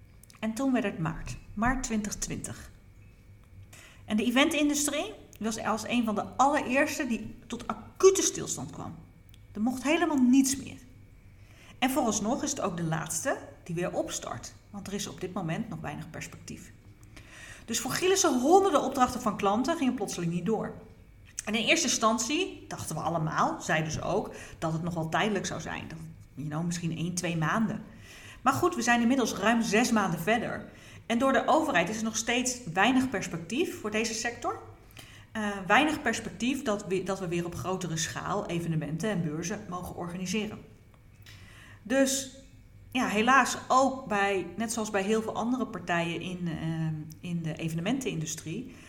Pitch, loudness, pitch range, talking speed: 205 Hz, -29 LUFS, 165-250 Hz, 165 wpm